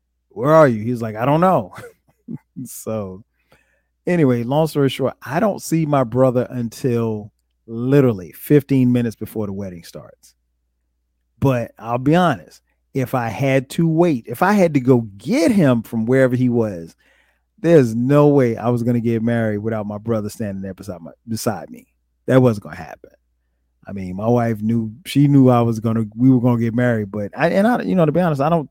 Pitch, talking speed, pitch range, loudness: 120 Hz, 205 wpm, 105-140 Hz, -18 LUFS